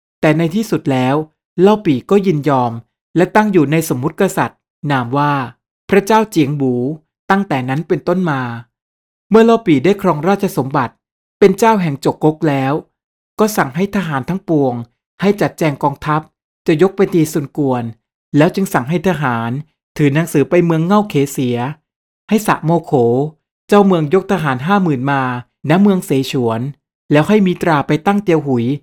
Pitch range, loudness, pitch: 135-185 Hz, -15 LUFS, 155 Hz